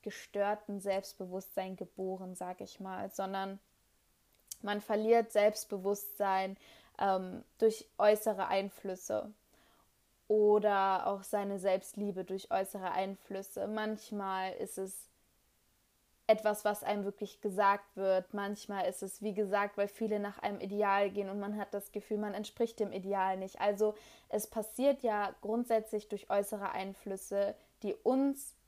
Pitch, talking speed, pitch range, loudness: 200 Hz, 130 wpm, 195-210 Hz, -35 LUFS